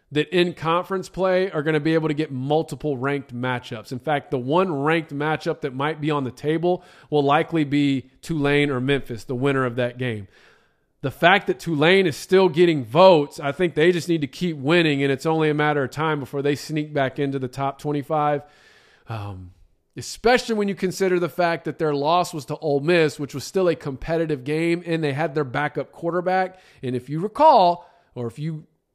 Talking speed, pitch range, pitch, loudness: 210 wpm, 140-170 Hz, 150 Hz, -22 LUFS